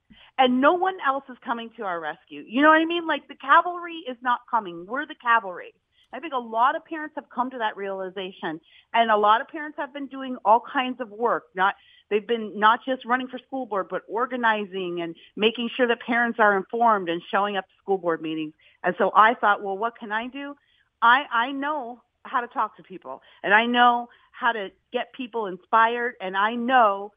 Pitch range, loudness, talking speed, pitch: 200-260 Hz, -24 LUFS, 220 wpm, 235 Hz